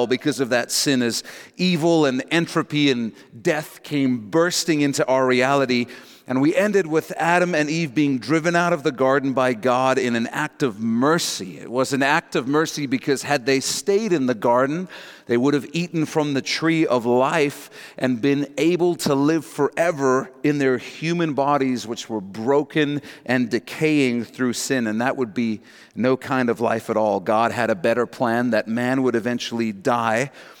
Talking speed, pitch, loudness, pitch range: 185 wpm, 135 Hz, -21 LUFS, 125-155 Hz